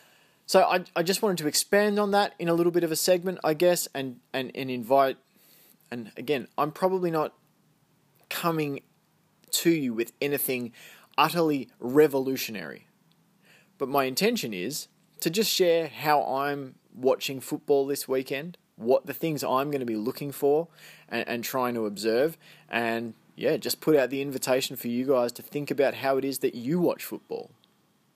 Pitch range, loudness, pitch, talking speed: 130-170 Hz, -27 LUFS, 145 Hz, 175 wpm